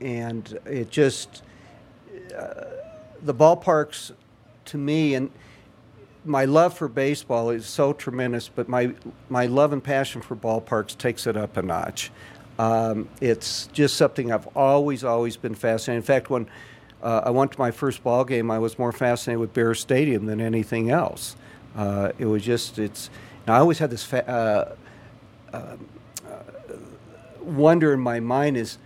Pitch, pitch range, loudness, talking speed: 120 Hz, 115-135 Hz, -23 LUFS, 160 wpm